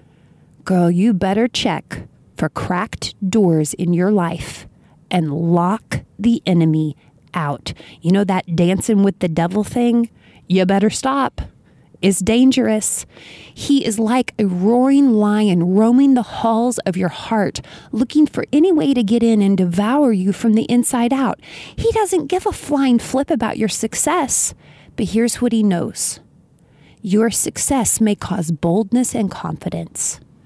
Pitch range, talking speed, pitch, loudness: 185-245 Hz, 150 wpm, 215 Hz, -17 LUFS